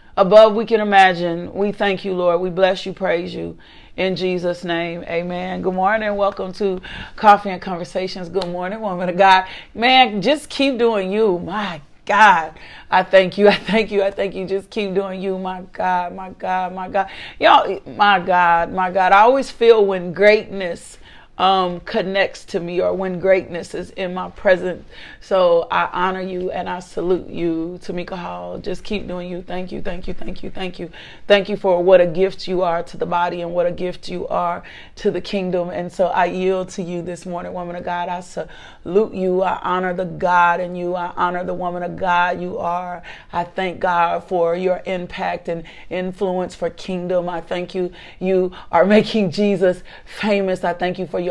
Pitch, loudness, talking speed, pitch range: 185 Hz, -18 LUFS, 200 wpm, 175-195 Hz